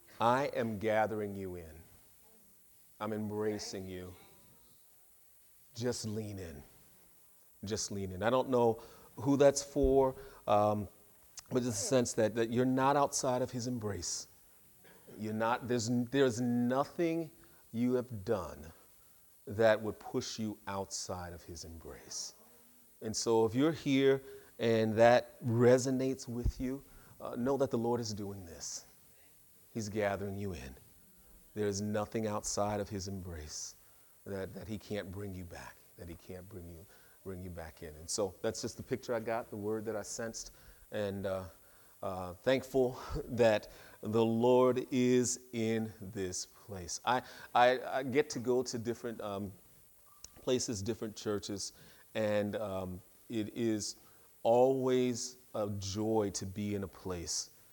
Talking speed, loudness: 150 wpm, -34 LUFS